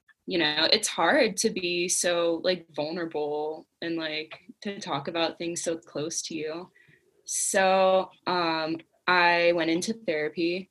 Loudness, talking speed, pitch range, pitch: -26 LUFS, 140 wpm, 160-185 Hz, 170 Hz